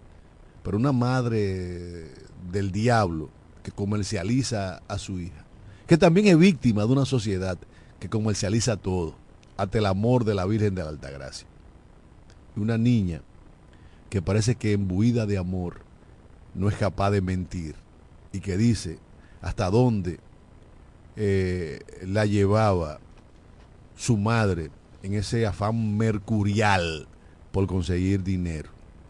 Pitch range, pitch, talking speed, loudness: 85-110 Hz, 100 Hz, 125 wpm, -25 LUFS